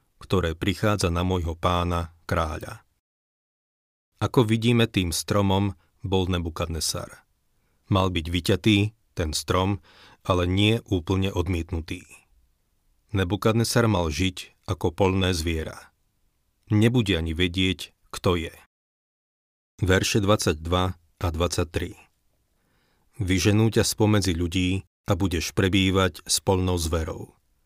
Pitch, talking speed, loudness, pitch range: 95 Hz, 100 wpm, -24 LUFS, 85-100 Hz